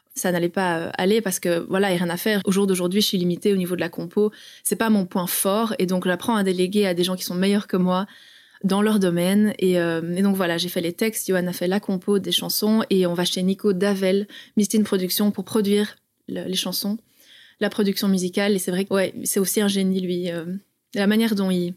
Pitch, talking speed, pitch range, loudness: 195 Hz, 255 wpm, 180-210 Hz, -22 LUFS